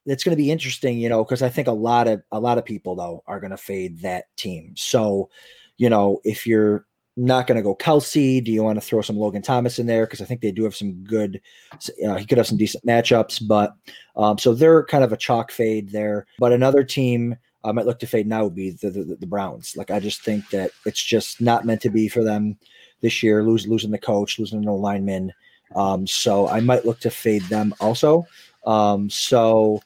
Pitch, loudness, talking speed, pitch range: 110 Hz, -21 LUFS, 235 wpm, 105-120 Hz